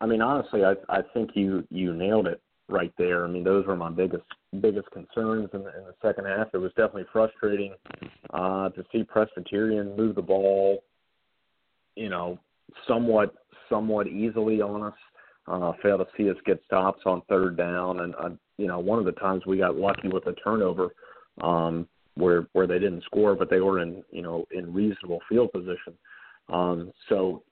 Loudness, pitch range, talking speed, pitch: -27 LUFS, 90-105 Hz, 190 wpm, 95 Hz